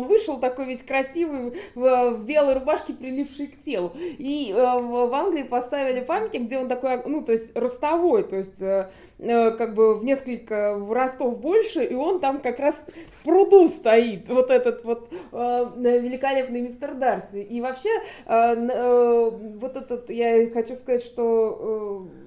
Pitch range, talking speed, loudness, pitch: 235-285 Hz, 160 wpm, -23 LUFS, 250 Hz